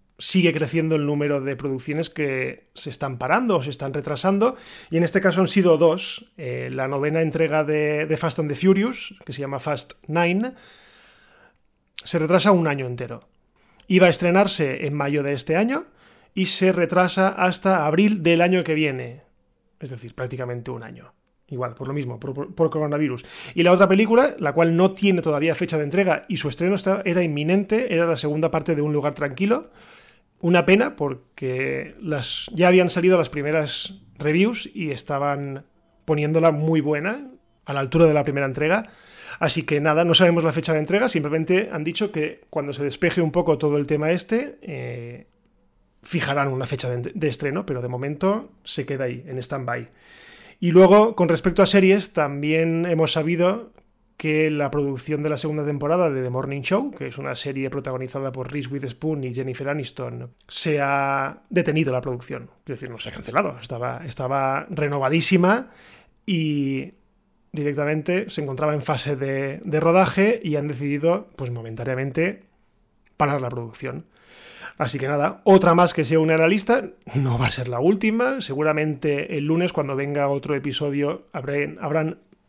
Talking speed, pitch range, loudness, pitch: 175 wpm, 140-180 Hz, -22 LUFS, 155 Hz